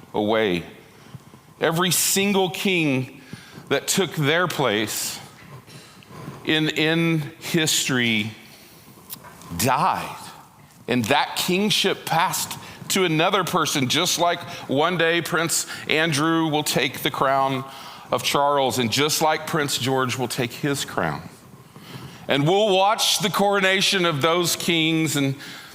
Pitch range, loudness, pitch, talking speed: 135-175 Hz, -21 LUFS, 155 Hz, 115 wpm